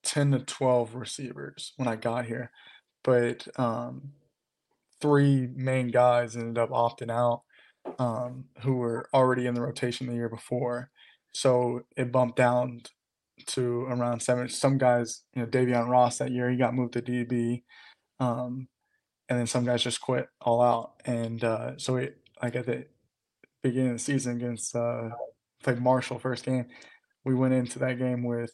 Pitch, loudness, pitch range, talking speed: 125 Hz, -28 LUFS, 120-130 Hz, 165 wpm